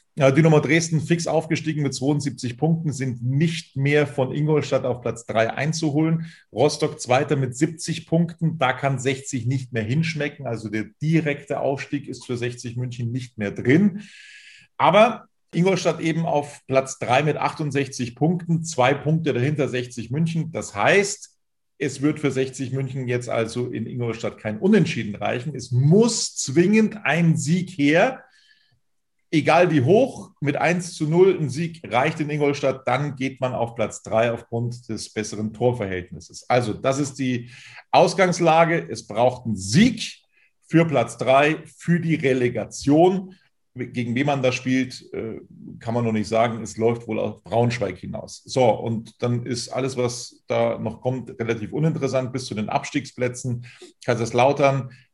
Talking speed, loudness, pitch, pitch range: 155 wpm, -22 LUFS, 135 Hz, 120-160 Hz